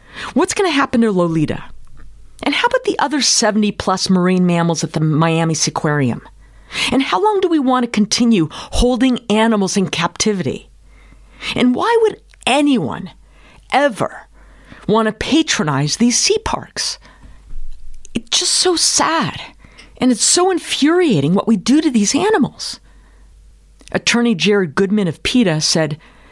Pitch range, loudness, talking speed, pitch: 180-290 Hz, -15 LUFS, 140 wpm, 225 Hz